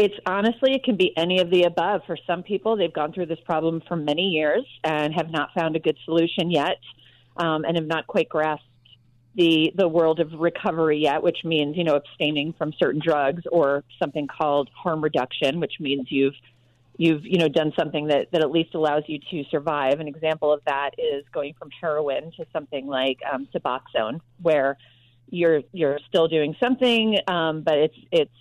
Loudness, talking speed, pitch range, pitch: -23 LUFS, 195 wpm, 145-175 Hz, 160 Hz